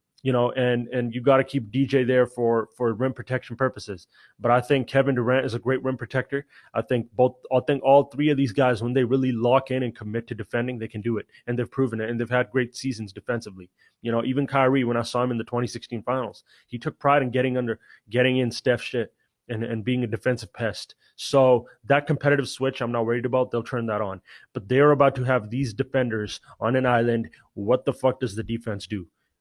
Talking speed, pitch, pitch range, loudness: 235 wpm, 125 Hz, 115-130 Hz, -24 LUFS